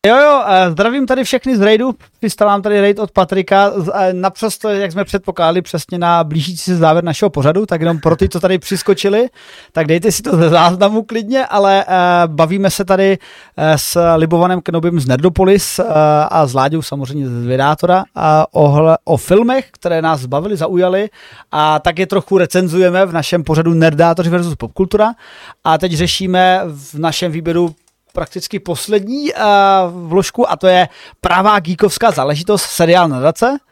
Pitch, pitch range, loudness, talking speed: 180 Hz, 165-200 Hz, -13 LUFS, 155 wpm